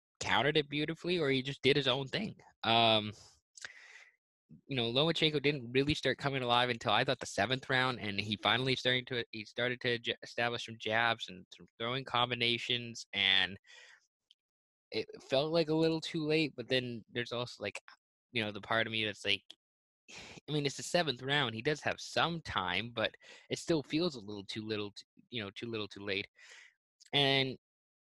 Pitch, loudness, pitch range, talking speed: 125 Hz, -33 LUFS, 110-145 Hz, 190 wpm